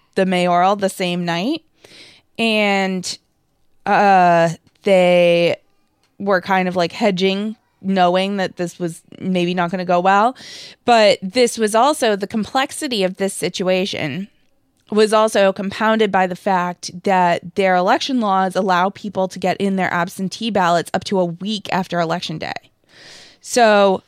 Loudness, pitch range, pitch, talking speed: -17 LUFS, 180-210 Hz, 190 Hz, 145 wpm